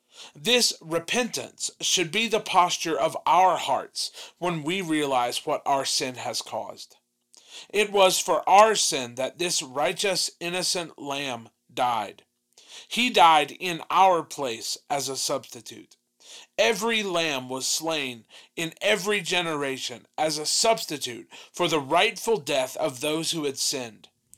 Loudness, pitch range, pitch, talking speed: -24 LUFS, 140-190 Hz, 165 Hz, 135 wpm